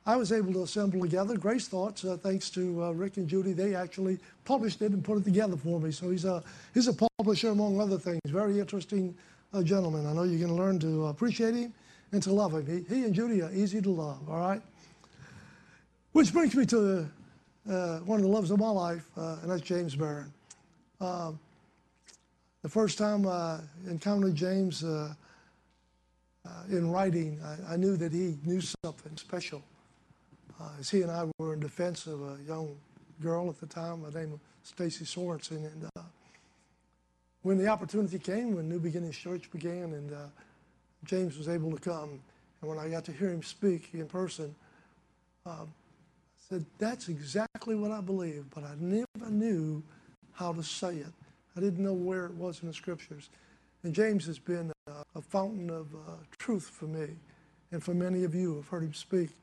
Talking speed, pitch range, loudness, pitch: 195 wpm, 160-195 Hz, -32 LUFS, 175 Hz